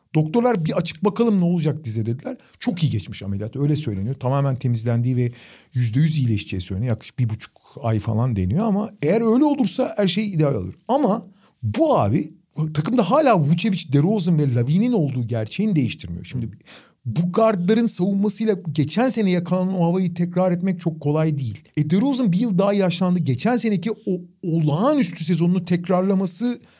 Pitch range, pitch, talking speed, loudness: 135-210 Hz, 175 Hz, 165 wpm, -21 LUFS